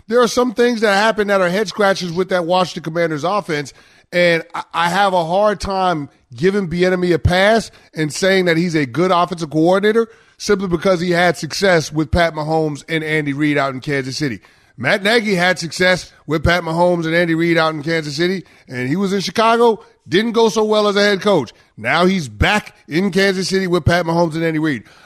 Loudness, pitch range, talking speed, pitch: -16 LUFS, 160-195 Hz, 210 wpm, 175 Hz